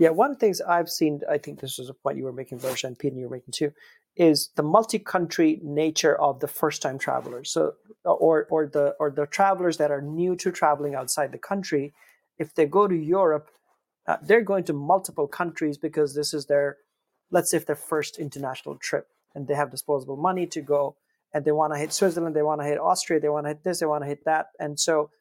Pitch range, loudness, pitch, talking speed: 145-170 Hz, -25 LUFS, 155 Hz, 225 wpm